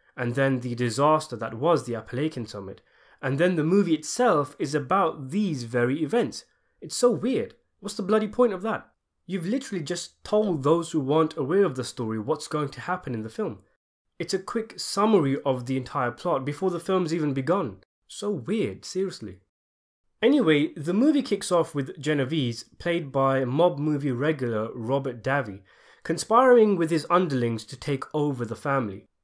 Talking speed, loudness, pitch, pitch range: 175 wpm, -25 LUFS, 155 Hz, 130-185 Hz